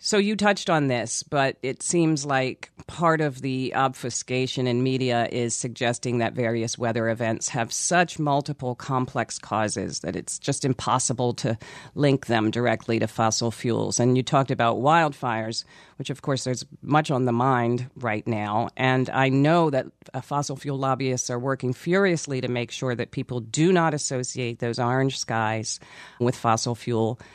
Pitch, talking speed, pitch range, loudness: 125 Hz, 165 wpm, 115-140 Hz, -24 LUFS